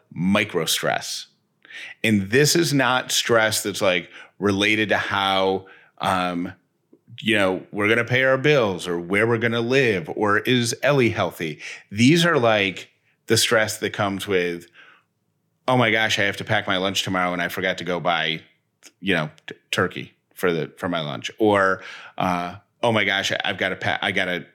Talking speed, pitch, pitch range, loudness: 180 wpm, 100 Hz, 95-115 Hz, -21 LUFS